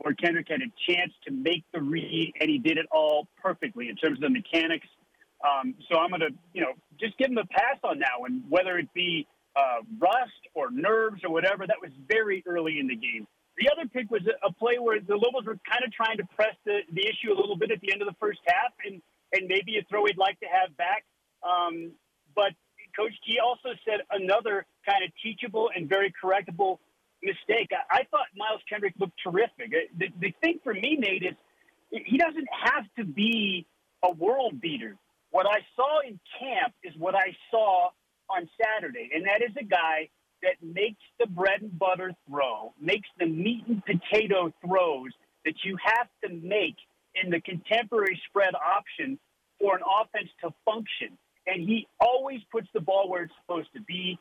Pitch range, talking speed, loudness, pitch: 180-235 Hz, 200 wpm, -28 LUFS, 200 Hz